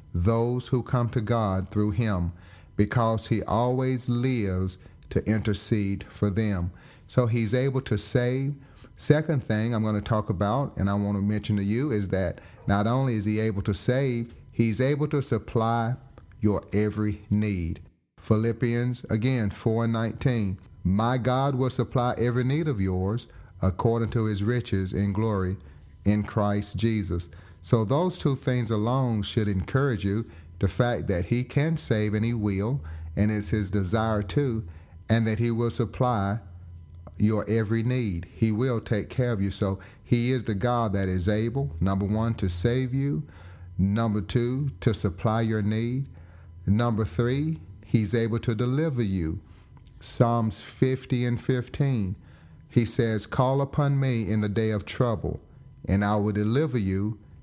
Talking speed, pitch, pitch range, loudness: 160 wpm, 110 Hz, 100-125 Hz, -26 LUFS